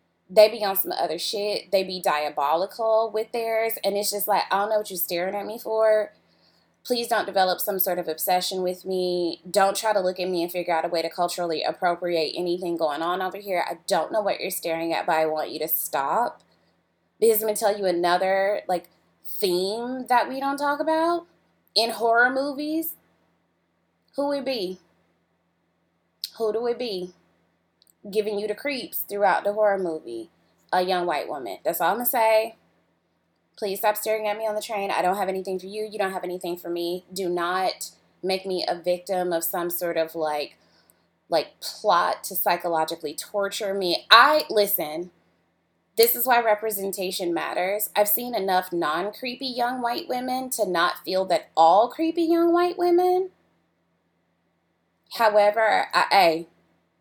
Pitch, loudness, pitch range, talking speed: 195 Hz, -24 LUFS, 175-220 Hz, 180 wpm